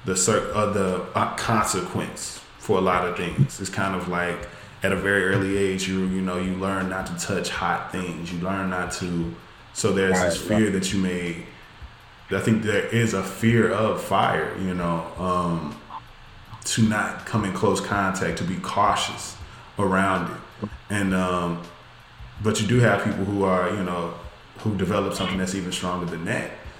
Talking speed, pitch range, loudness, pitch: 180 wpm, 90-105 Hz, -24 LUFS, 95 Hz